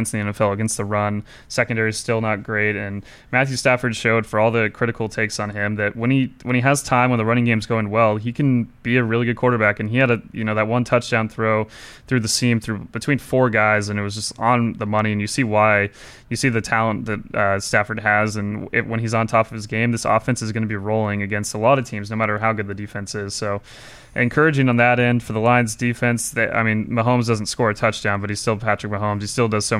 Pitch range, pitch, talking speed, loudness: 105-120 Hz, 110 Hz, 270 wpm, -20 LUFS